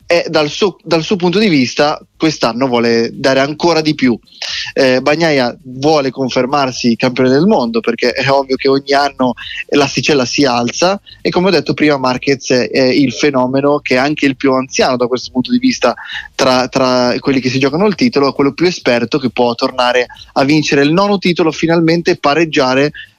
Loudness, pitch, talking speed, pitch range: -13 LUFS, 140 Hz, 185 wpm, 130-160 Hz